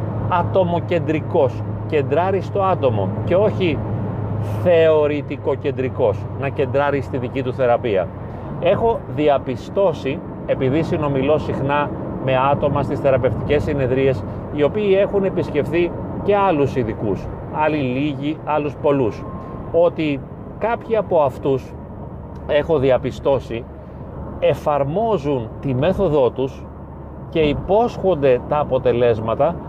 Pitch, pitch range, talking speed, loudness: 140 Hz, 125-150 Hz, 100 wpm, -19 LUFS